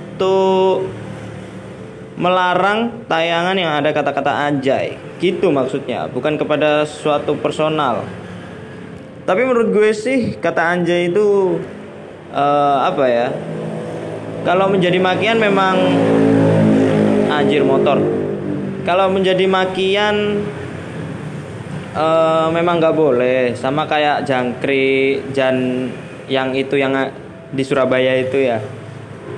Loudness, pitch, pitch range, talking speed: -16 LUFS, 155 Hz, 135-185 Hz, 100 wpm